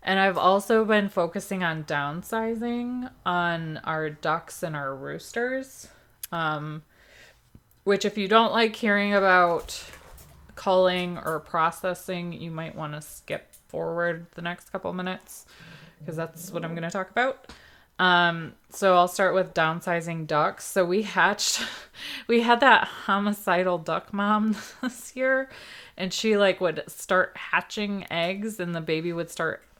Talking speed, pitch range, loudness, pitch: 145 wpm, 165-205 Hz, -25 LUFS, 180 Hz